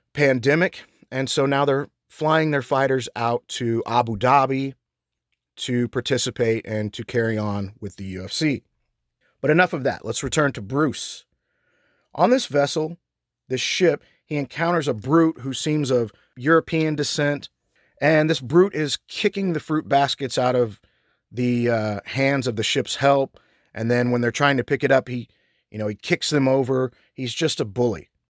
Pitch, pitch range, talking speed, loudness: 130 Hz, 120-145 Hz, 170 wpm, -22 LUFS